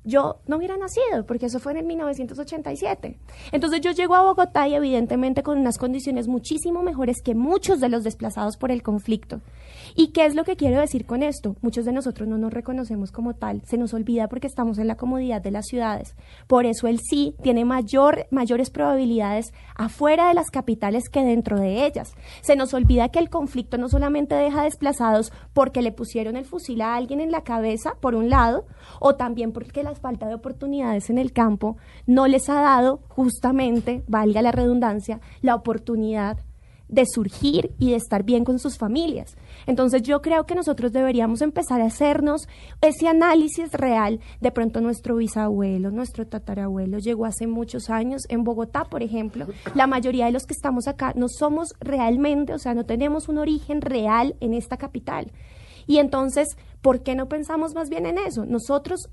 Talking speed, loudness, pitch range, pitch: 185 wpm, -22 LUFS, 230-290 Hz, 255 Hz